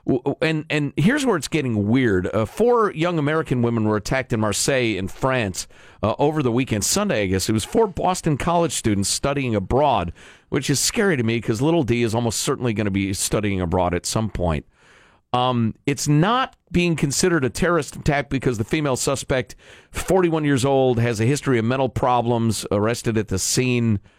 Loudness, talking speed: -21 LUFS, 190 wpm